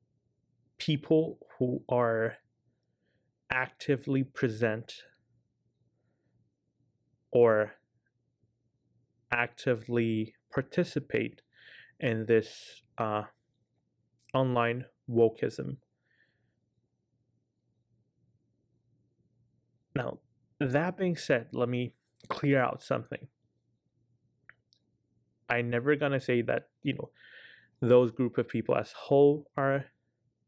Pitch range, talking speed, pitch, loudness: 115-135 Hz, 70 wpm, 120 Hz, -30 LUFS